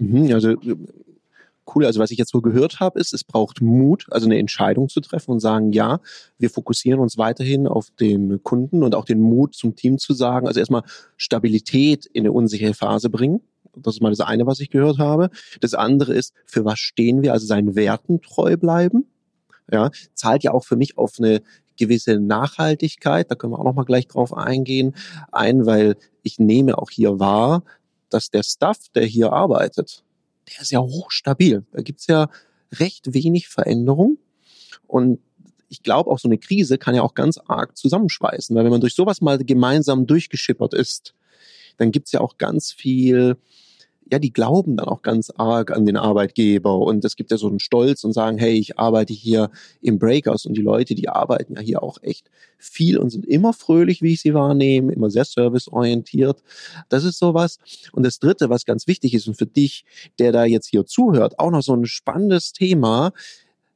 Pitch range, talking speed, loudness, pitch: 115-150 Hz, 195 wpm, -18 LUFS, 125 Hz